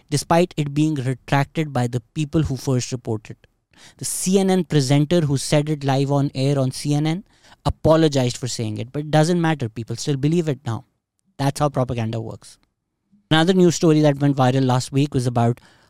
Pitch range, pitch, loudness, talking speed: 125-155 Hz, 140 Hz, -20 LUFS, 180 wpm